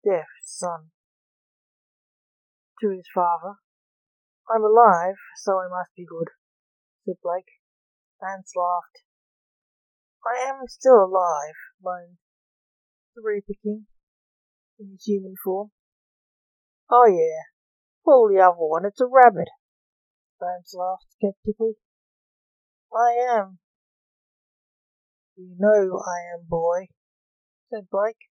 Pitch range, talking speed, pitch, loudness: 180-225 Hz, 100 wpm, 195 Hz, -21 LUFS